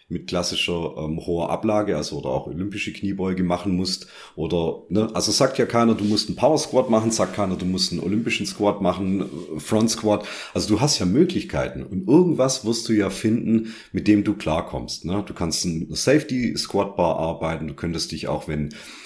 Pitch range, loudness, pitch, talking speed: 85-110 Hz, -22 LUFS, 95 Hz, 195 wpm